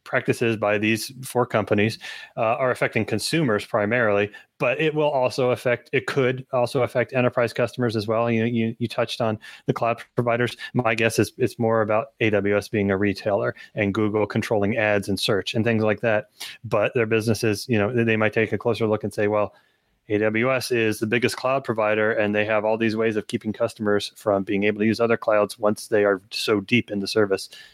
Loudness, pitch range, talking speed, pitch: -23 LUFS, 105-120 Hz, 205 wpm, 110 Hz